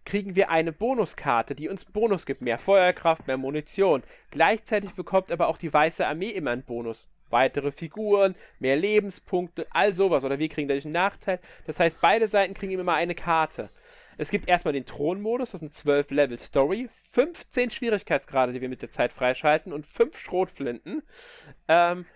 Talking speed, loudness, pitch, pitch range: 175 wpm, -25 LUFS, 175 Hz, 145-200 Hz